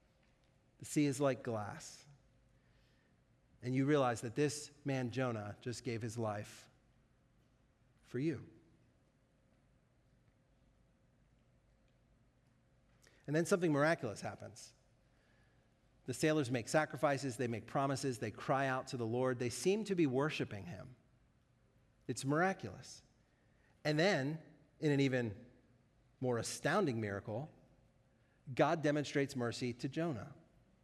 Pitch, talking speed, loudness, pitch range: 130 Hz, 110 wpm, -38 LUFS, 120-140 Hz